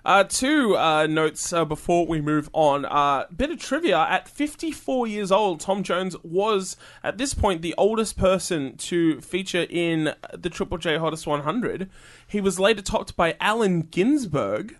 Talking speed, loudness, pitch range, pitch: 165 wpm, -23 LUFS, 160-205 Hz, 180 Hz